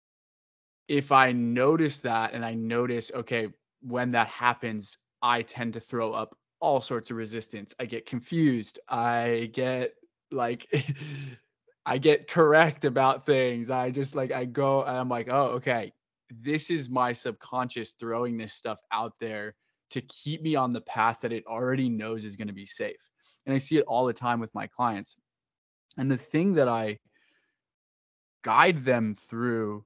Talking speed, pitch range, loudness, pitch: 165 wpm, 115-135 Hz, -28 LUFS, 125 Hz